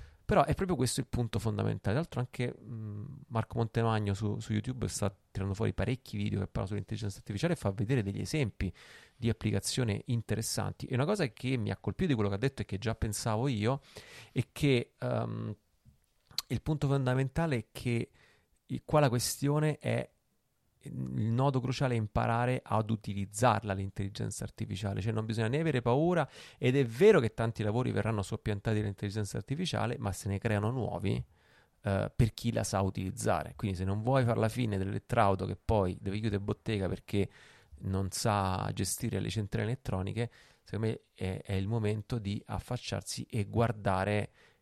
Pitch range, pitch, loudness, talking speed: 100-125 Hz, 110 Hz, -33 LUFS, 170 wpm